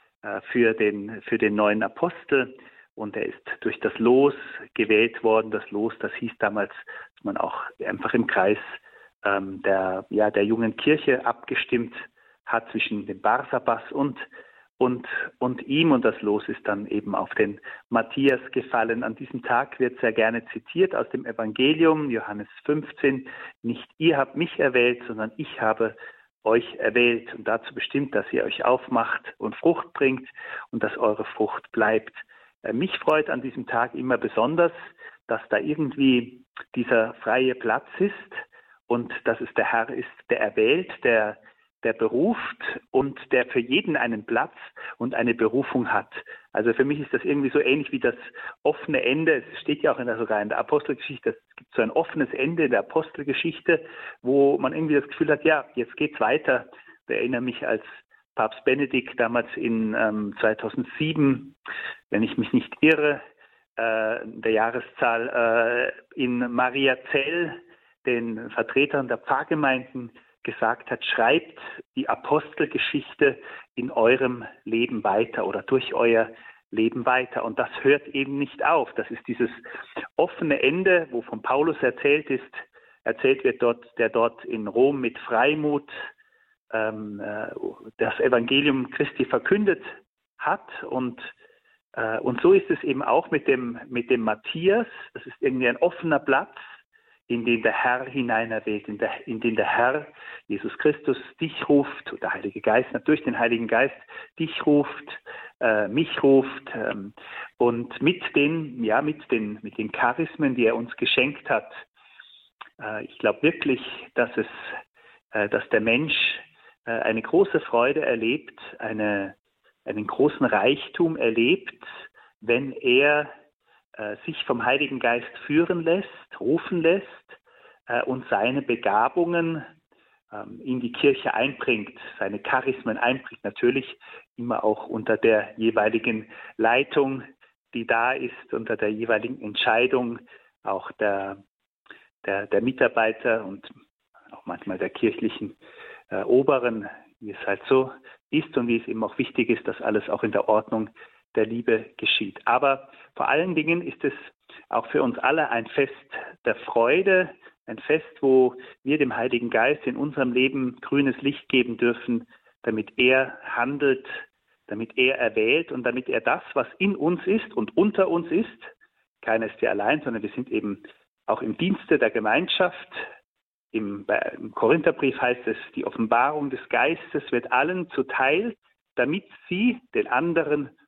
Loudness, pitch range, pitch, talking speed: -24 LUFS, 115-170 Hz, 135 Hz, 150 wpm